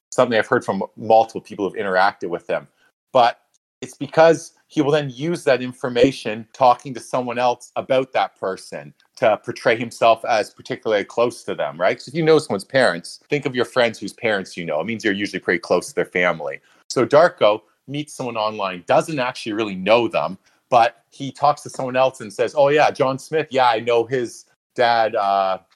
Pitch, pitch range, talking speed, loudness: 125 Hz, 115-140 Hz, 200 wpm, -20 LUFS